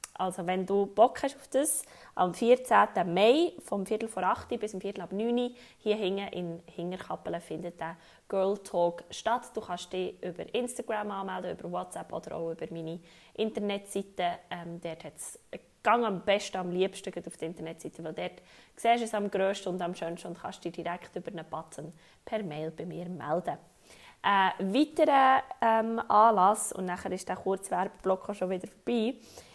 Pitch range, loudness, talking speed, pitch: 175-220 Hz, -30 LUFS, 180 wpm, 190 Hz